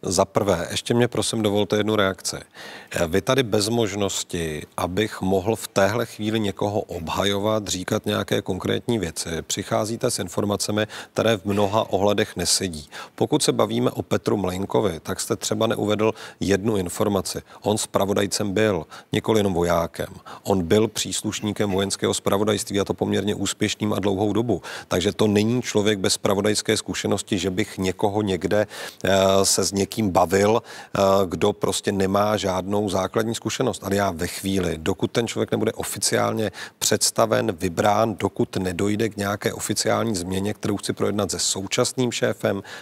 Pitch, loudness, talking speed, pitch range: 105 Hz, -23 LUFS, 145 wpm, 95-110 Hz